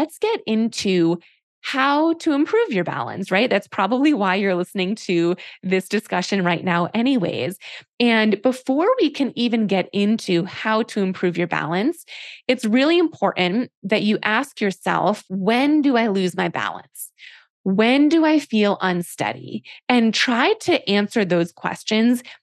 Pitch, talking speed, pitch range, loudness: 220 Hz, 150 wpm, 190-265 Hz, -20 LUFS